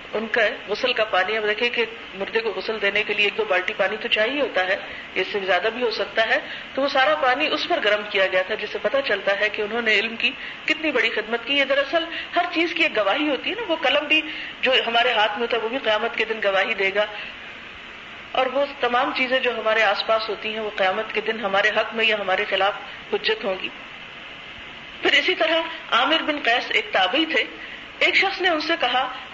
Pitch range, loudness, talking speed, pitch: 210-280 Hz, -21 LUFS, 240 wpm, 225 Hz